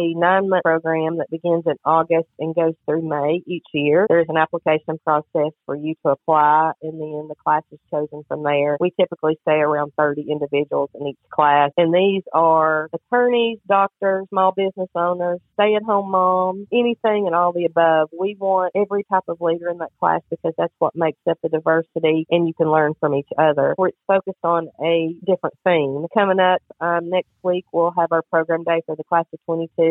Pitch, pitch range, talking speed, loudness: 165 Hz, 155-185 Hz, 195 wpm, -19 LUFS